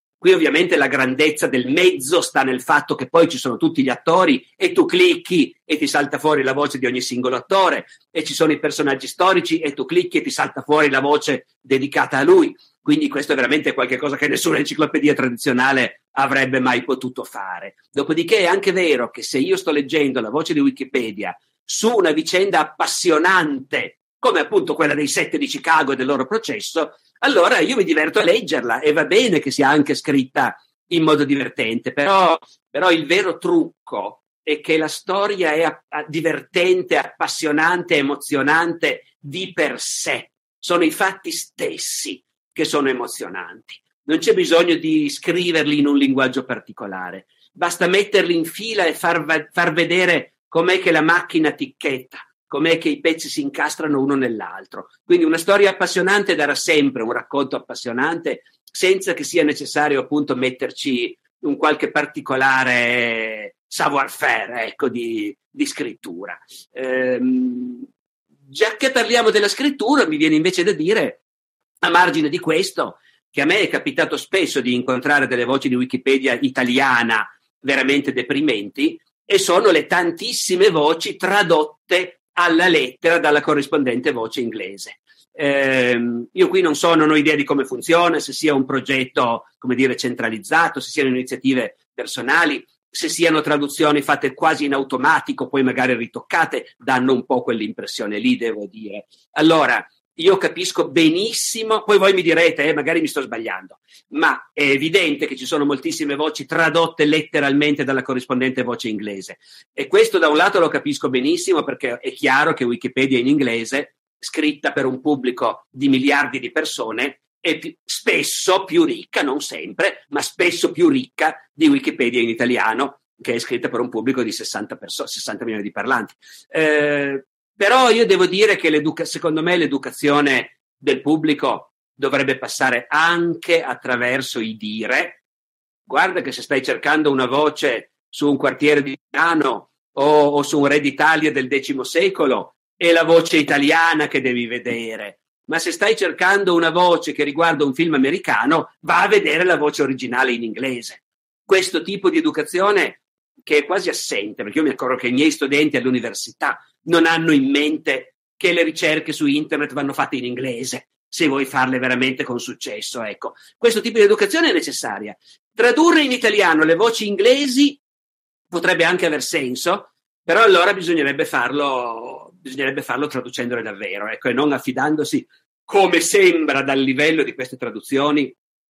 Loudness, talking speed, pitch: -18 LUFS, 160 wpm, 155 Hz